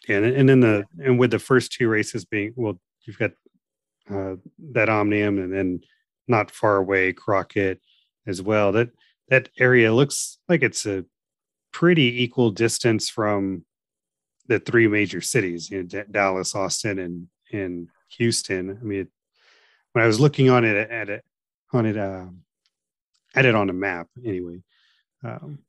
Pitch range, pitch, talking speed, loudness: 95-120 Hz, 105 Hz, 165 wpm, -22 LUFS